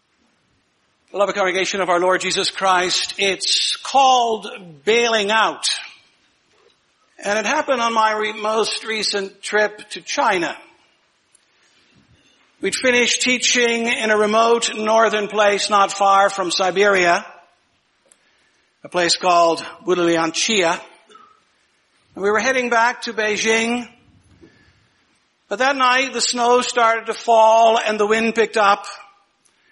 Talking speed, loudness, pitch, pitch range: 120 wpm, -17 LUFS, 215 Hz, 195-235 Hz